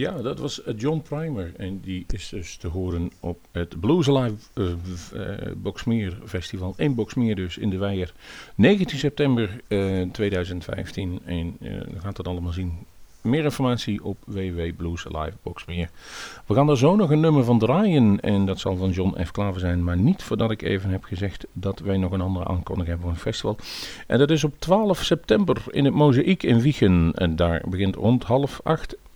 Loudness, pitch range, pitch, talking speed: -24 LUFS, 90-125 Hz, 100 Hz, 185 wpm